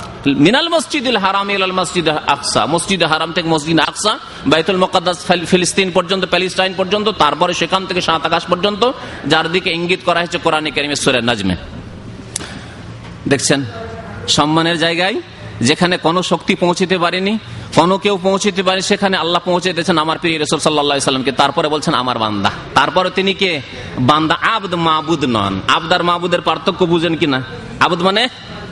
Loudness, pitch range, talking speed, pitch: -15 LUFS, 155-185 Hz, 145 wpm, 175 Hz